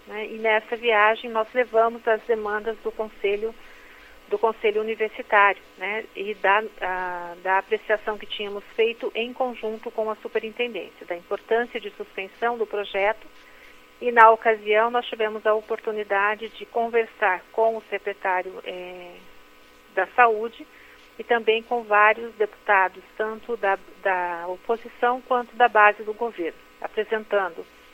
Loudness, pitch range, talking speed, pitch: -23 LUFS, 200-230 Hz, 135 wpm, 215 Hz